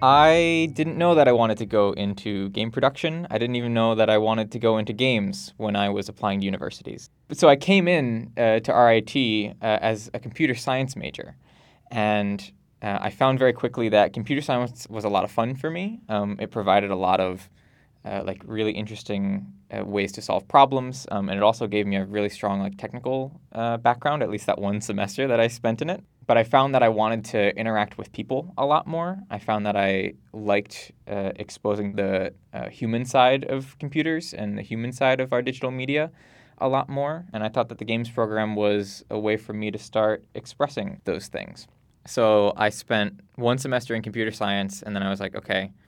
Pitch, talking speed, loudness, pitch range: 110 Hz, 215 wpm, -24 LUFS, 105-130 Hz